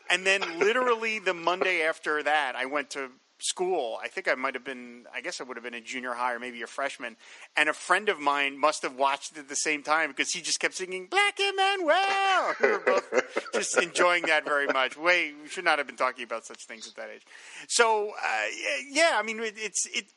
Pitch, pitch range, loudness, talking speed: 160 Hz, 140-220 Hz, -27 LUFS, 235 wpm